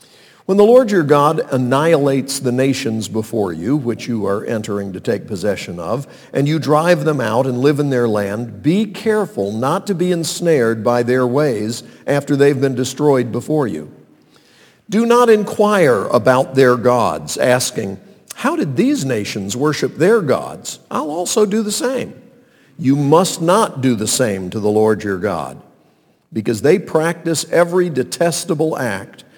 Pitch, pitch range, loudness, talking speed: 140 Hz, 120-170 Hz, -16 LUFS, 160 wpm